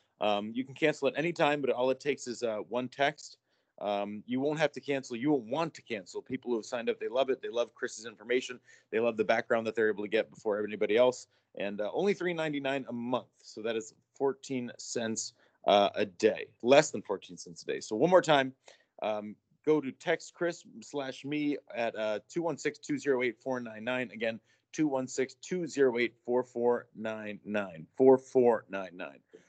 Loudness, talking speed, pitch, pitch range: -32 LUFS, 185 wpm, 130 Hz, 115-150 Hz